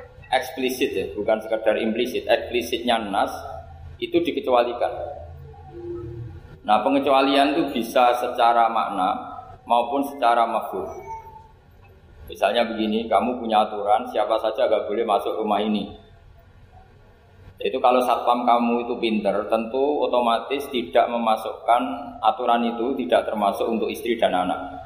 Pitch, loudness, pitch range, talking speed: 115 Hz, -22 LUFS, 105-125 Hz, 115 wpm